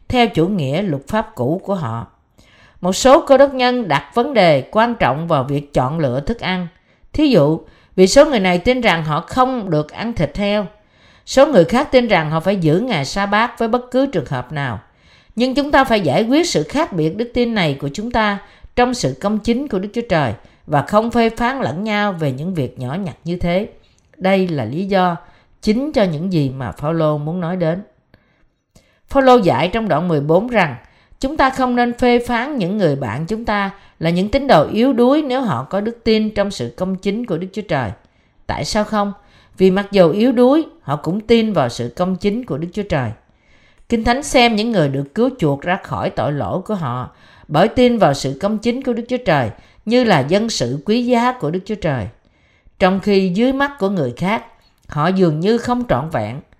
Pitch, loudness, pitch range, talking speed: 195 Hz, -17 LUFS, 155-235 Hz, 220 wpm